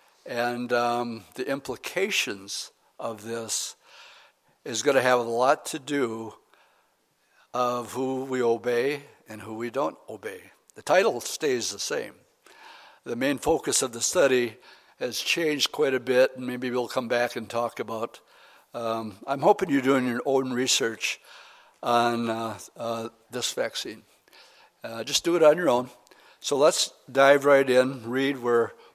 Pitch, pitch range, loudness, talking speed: 125 Hz, 115-135 Hz, -26 LUFS, 155 wpm